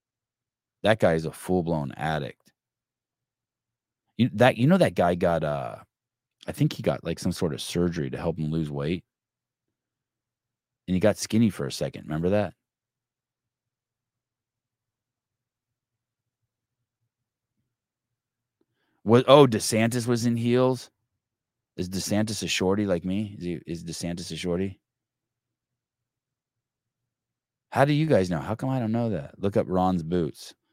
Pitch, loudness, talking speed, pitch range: 115 Hz, -25 LUFS, 140 wpm, 90-125 Hz